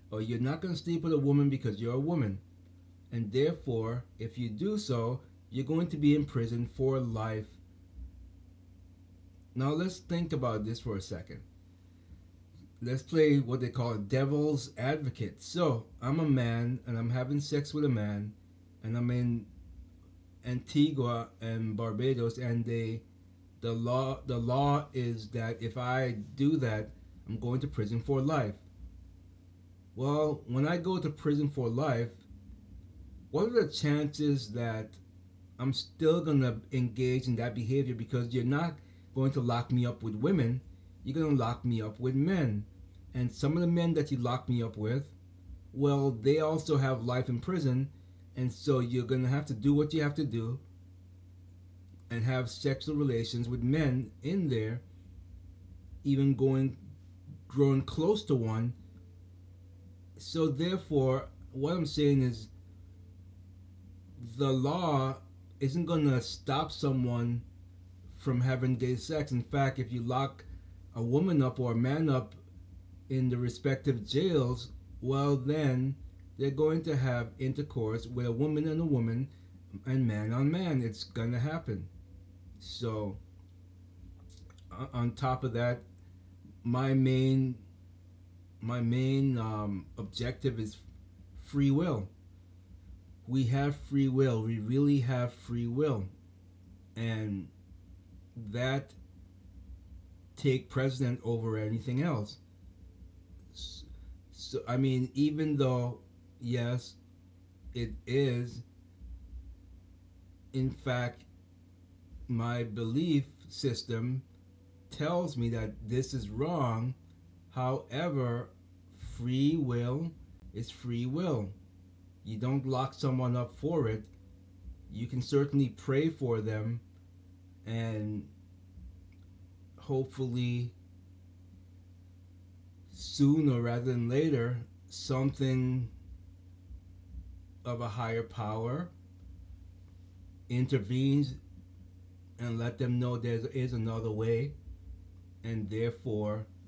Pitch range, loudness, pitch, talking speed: 90-130 Hz, -32 LUFS, 115 Hz, 125 wpm